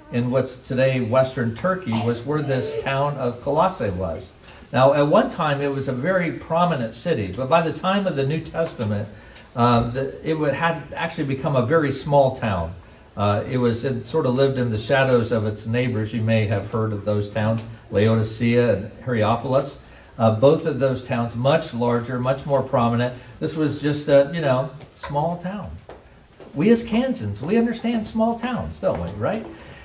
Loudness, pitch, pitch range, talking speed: -22 LUFS, 130 Hz, 115-150 Hz, 185 wpm